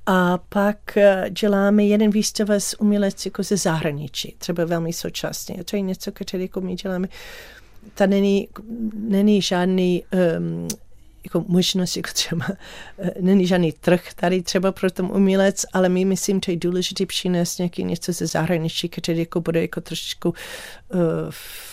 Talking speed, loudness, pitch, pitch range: 155 wpm, -21 LUFS, 185 Hz, 175-200 Hz